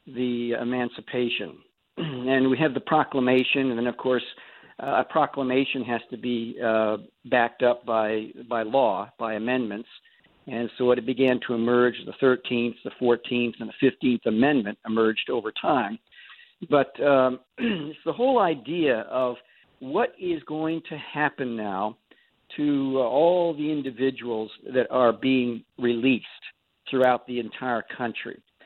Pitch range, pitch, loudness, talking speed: 120-135 Hz, 125 Hz, -25 LUFS, 140 wpm